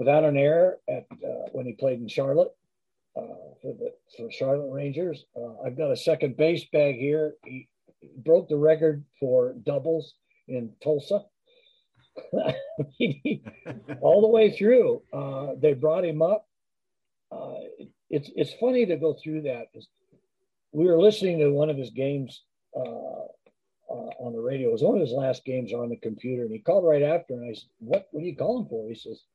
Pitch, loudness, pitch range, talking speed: 155 Hz, -25 LUFS, 135-210 Hz, 180 wpm